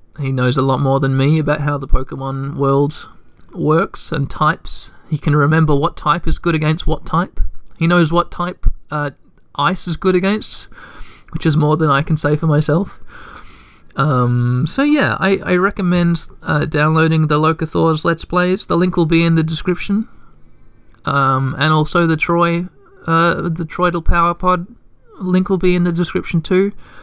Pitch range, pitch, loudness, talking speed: 145-175 Hz, 160 Hz, -16 LUFS, 175 wpm